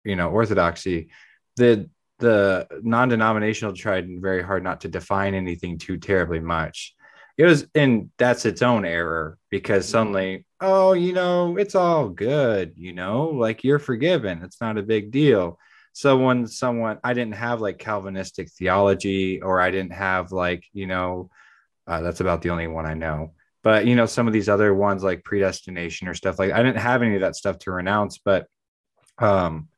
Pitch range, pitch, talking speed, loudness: 90-120 Hz, 100 Hz, 180 wpm, -22 LUFS